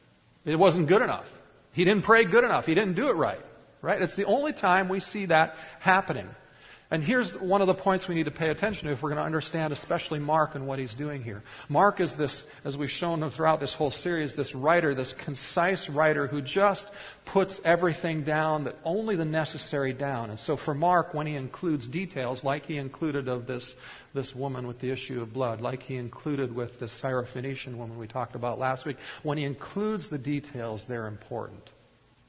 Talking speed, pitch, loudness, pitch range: 205 wpm, 150 Hz, -28 LUFS, 130-175 Hz